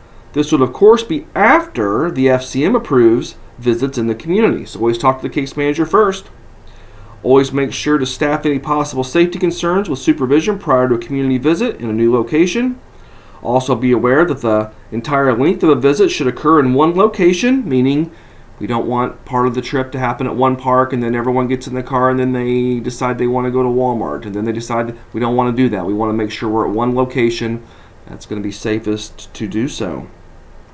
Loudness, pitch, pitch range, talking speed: -15 LUFS, 125 Hz, 115-140 Hz, 220 wpm